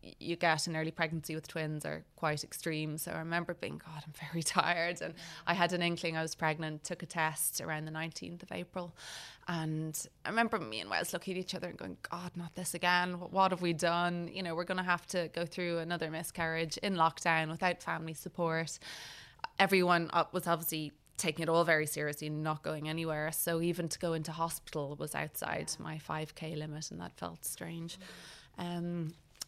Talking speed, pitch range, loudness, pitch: 200 wpm, 155-175 Hz, -35 LUFS, 165 Hz